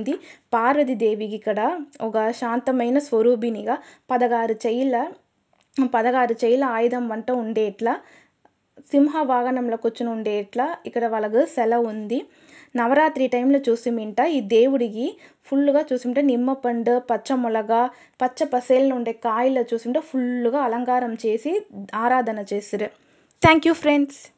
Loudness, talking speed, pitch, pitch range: -22 LUFS, 110 wpm, 245 Hz, 230-270 Hz